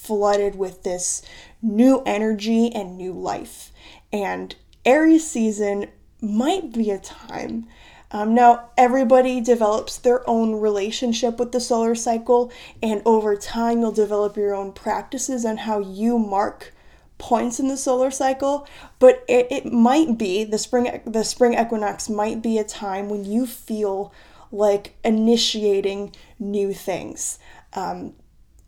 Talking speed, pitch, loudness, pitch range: 135 wpm, 225 Hz, -21 LUFS, 205-245 Hz